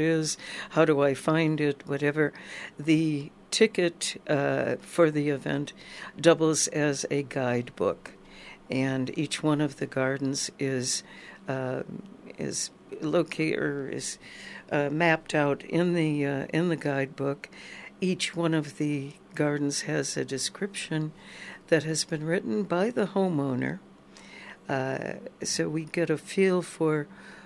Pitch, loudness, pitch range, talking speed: 155 Hz, -28 LUFS, 140-170 Hz, 130 wpm